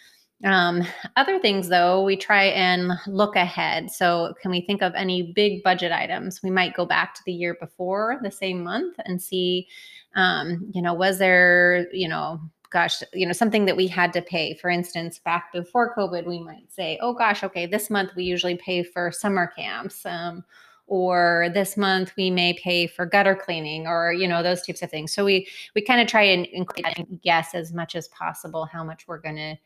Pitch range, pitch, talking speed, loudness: 175-195 Hz, 180 Hz, 205 wpm, -22 LUFS